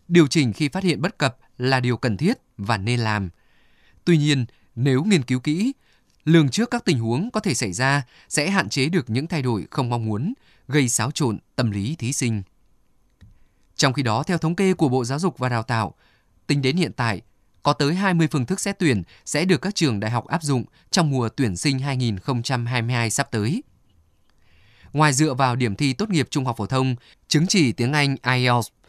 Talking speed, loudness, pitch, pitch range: 210 wpm, -22 LUFS, 130 Hz, 115-155 Hz